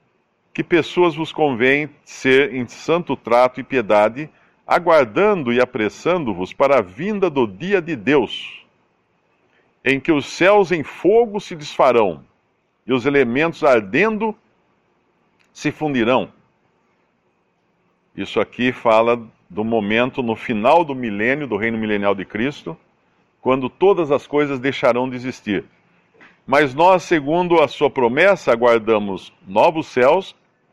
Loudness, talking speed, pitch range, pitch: -18 LUFS, 125 wpm, 120-165 Hz, 135 Hz